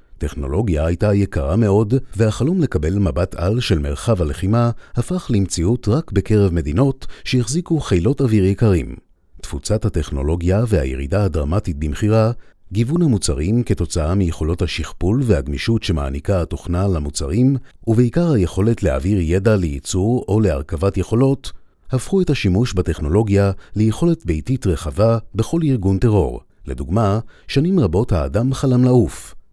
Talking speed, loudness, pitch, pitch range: 115 wpm, -18 LUFS, 100 Hz, 85-115 Hz